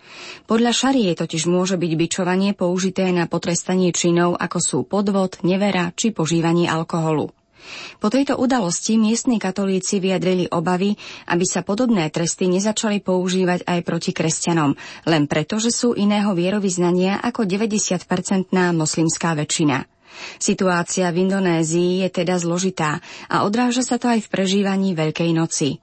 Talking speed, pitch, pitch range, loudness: 135 wpm, 185 Hz, 170-200 Hz, -20 LUFS